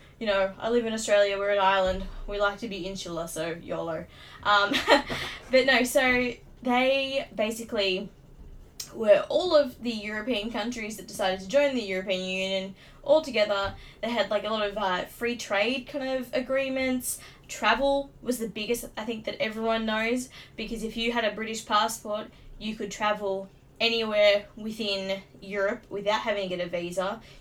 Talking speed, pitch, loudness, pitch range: 170 wpm, 215 Hz, -27 LUFS, 200-245 Hz